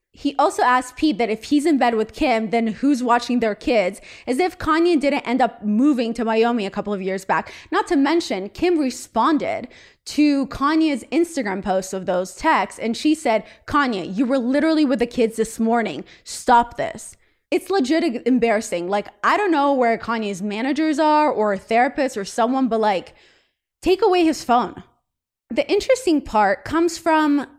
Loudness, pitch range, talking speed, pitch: -20 LUFS, 225-300 Hz, 180 wpm, 250 Hz